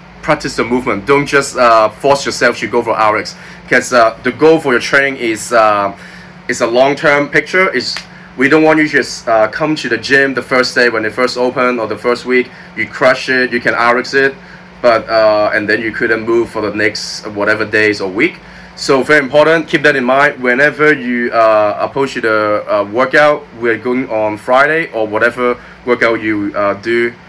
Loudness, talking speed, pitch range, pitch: -12 LUFS, 205 wpm, 115-150 Hz, 125 Hz